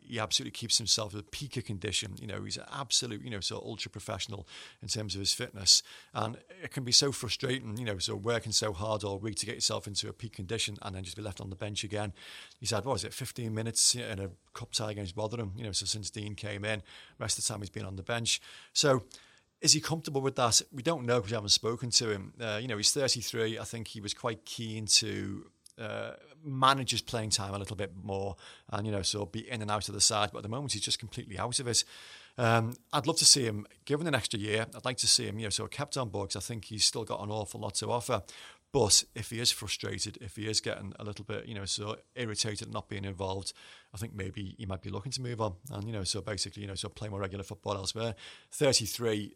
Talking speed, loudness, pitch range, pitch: 270 wpm, -31 LUFS, 100-115 Hz, 110 Hz